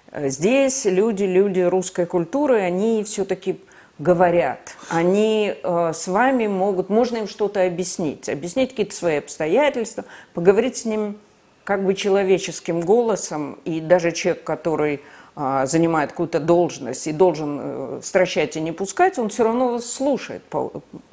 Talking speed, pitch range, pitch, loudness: 140 wpm, 170-215 Hz, 185 Hz, -21 LUFS